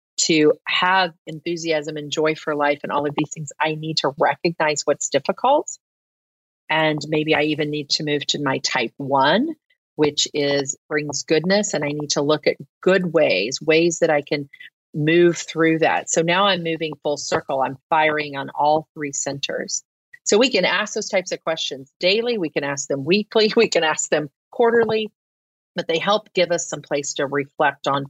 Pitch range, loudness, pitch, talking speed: 145-175 Hz, -20 LUFS, 155 Hz, 190 wpm